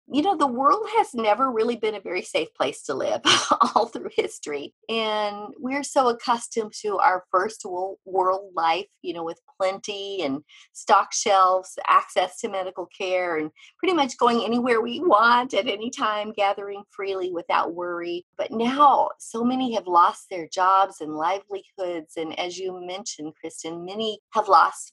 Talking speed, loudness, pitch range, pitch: 165 wpm, -23 LUFS, 185-245 Hz, 205 Hz